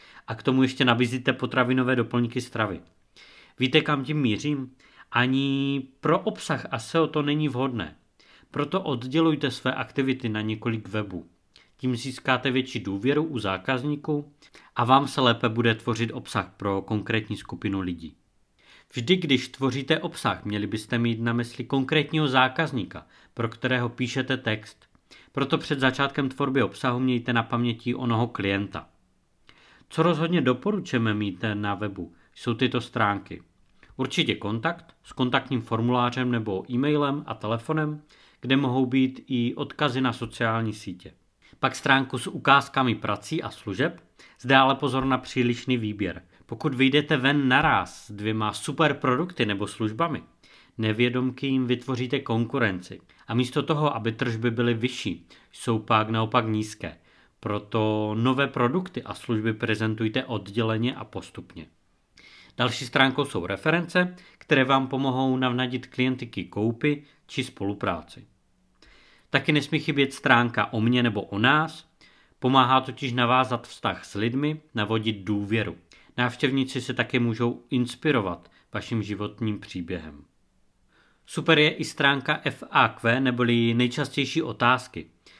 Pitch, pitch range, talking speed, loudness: 125 Hz, 110-140 Hz, 130 wpm, -25 LUFS